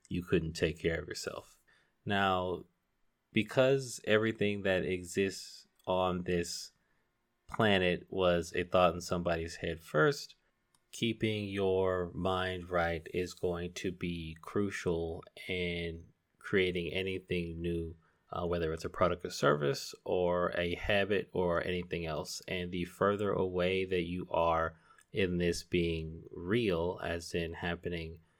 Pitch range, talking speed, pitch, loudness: 85-95 Hz, 130 wpm, 90 Hz, -34 LUFS